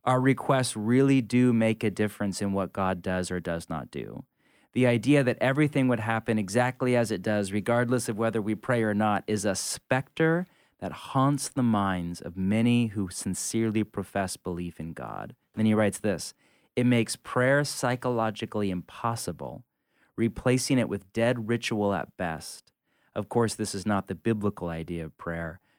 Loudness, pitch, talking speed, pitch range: -27 LUFS, 110 Hz, 170 wpm, 95-125 Hz